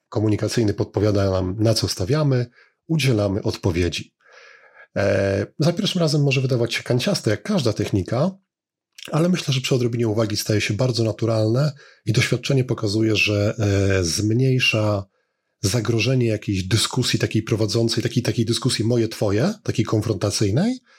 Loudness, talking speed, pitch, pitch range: -21 LUFS, 130 wpm, 115 Hz, 105-130 Hz